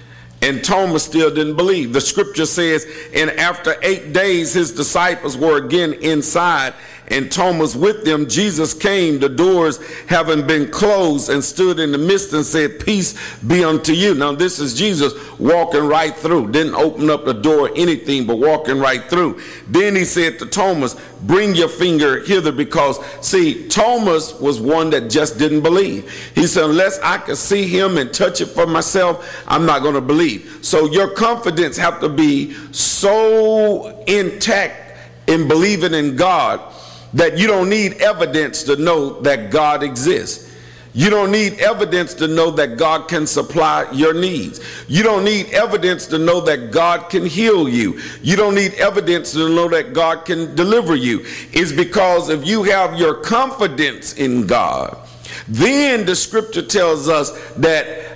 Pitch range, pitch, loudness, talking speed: 155-195 Hz, 165 Hz, -15 LUFS, 165 wpm